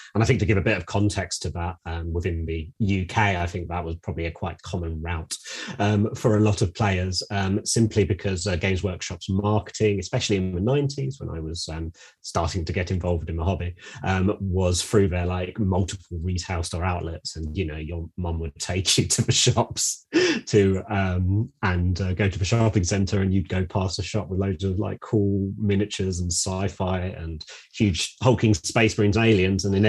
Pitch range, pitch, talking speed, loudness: 90-105 Hz, 95 Hz, 210 wpm, -24 LUFS